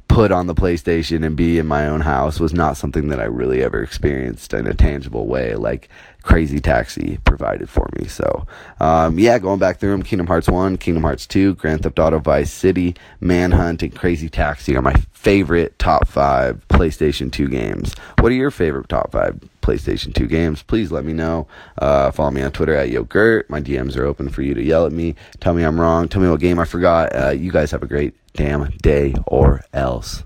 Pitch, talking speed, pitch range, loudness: 80 Hz, 215 wpm, 75-90 Hz, -18 LUFS